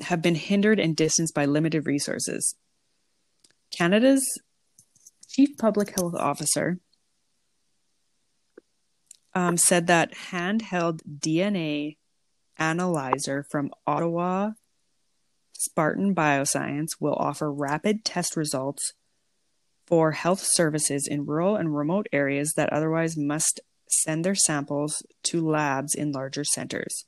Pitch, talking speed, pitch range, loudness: 160 Hz, 105 wpm, 150-180 Hz, -25 LUFS